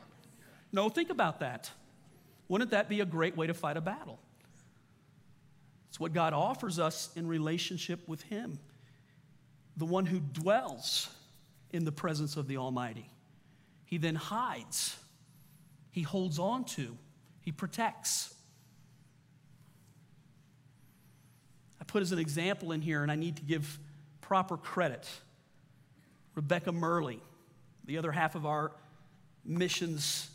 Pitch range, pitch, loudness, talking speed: 145-170 Hz, 155 Hz, -35 LUFS, 125 wpm